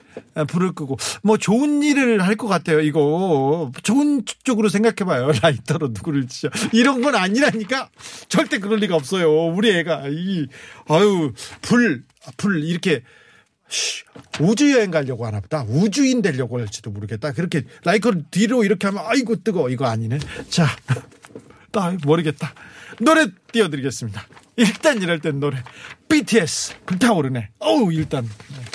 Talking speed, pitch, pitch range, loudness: 315 characters per minute, 170 Hz, 145-220 Hz, -19 LUFS